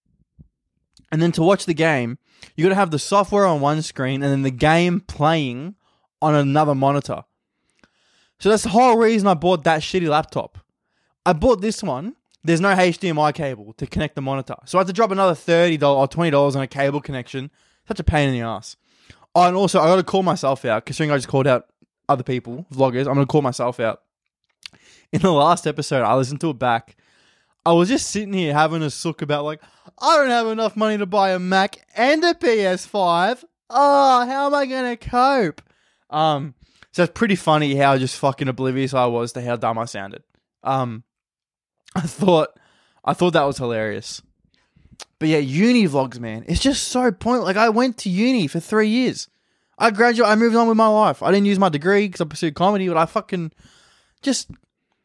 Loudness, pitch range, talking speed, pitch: -19 LUFS, 140-205 Hz, 200 wpm, 165 Hz